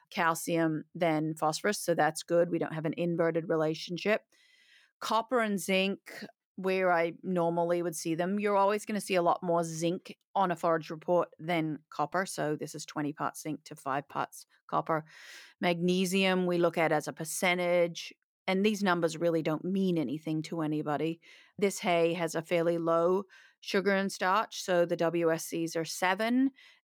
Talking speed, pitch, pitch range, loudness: 170 wpm, 170 Hz, 165-190 Hz, -31 LUFS